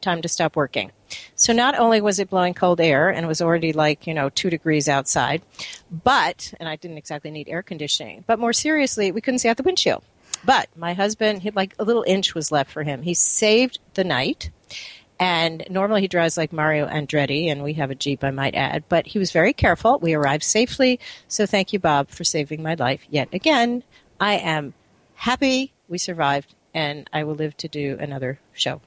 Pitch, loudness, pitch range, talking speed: 165 Hz, -21 LUFS, 150-205 Hz, 210 wpm